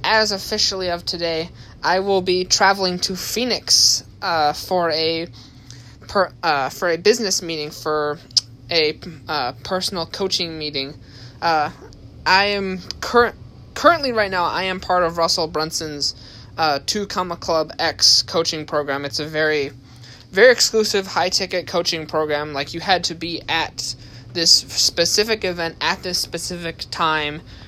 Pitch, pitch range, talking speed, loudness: 165 Hz, 140-185 Hz, 145 wpm, -19 LUFS